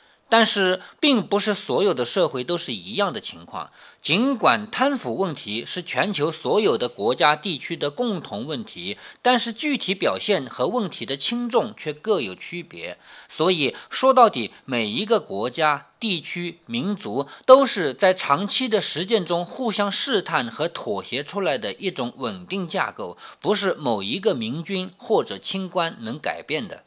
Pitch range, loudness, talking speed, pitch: 175-230 Hz, -22 LUFS, 245 characters per minute, 200 Hz